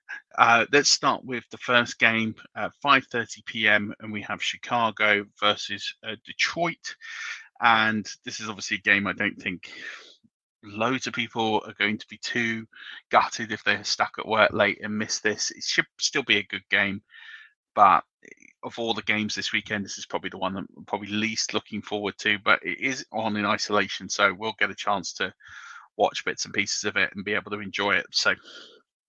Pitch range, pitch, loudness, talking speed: 105-120 Hz, 110 Hz, -25 LUFS, 195 wpm